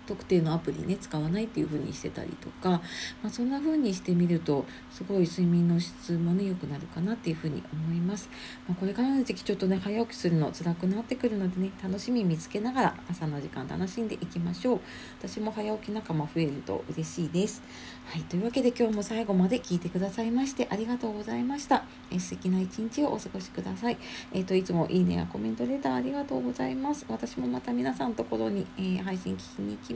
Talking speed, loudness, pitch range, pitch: 460 characters per minute, -30 LUFS, 160-220 Hz, 185 Hz